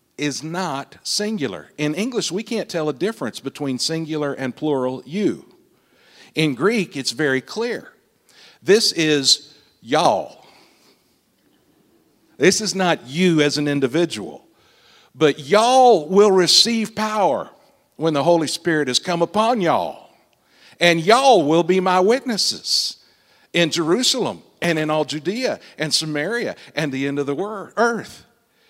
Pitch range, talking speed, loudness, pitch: 150-205 Hz, 135 wpm, -19 LUFS, 170 Hz